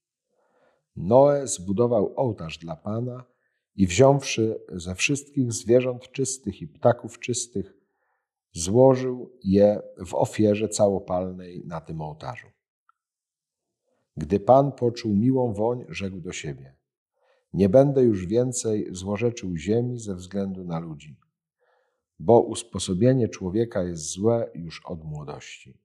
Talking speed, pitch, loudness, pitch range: 110 wpm, 105 Hz, -24 LUFS, 90-125 Hz